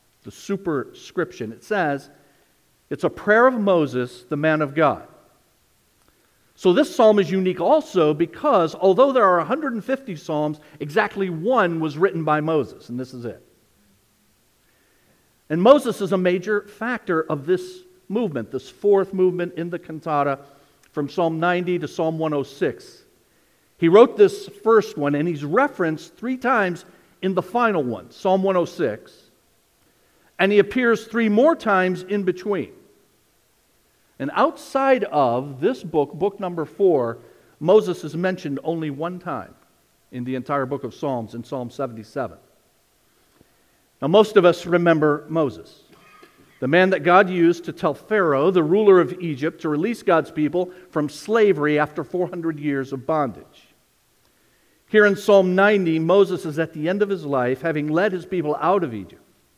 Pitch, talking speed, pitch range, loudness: 175 Hz, 150 wpm, 150-200 Hz, -20 LUFS